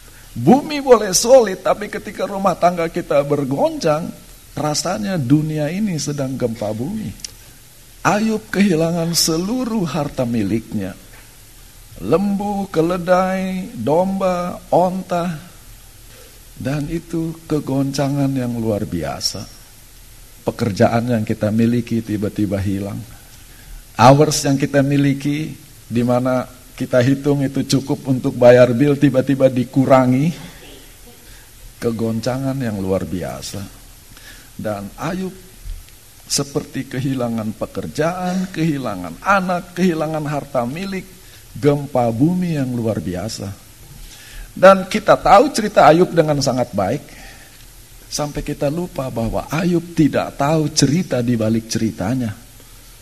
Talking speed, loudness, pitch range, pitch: 100 wpm, -18 LUFS, 115-165 Hz, 135 Hz